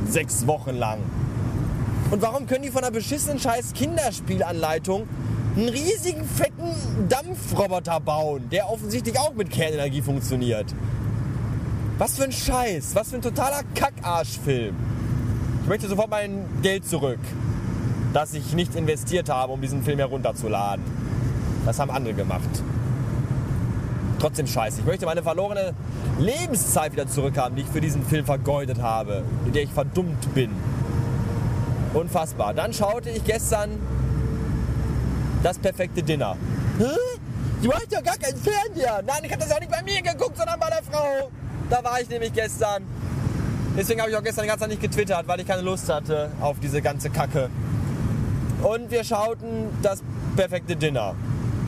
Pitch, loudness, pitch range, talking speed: 135 Hz, -25 LUFS, 120-170 Hz, 150 wpm